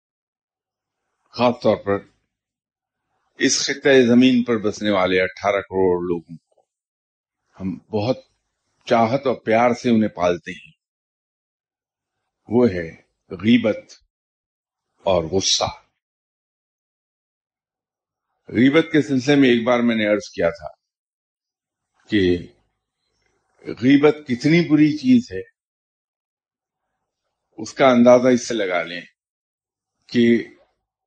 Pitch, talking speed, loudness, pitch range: 115 Hz, 100 wpm, -18 LUFS, 95-130 Hz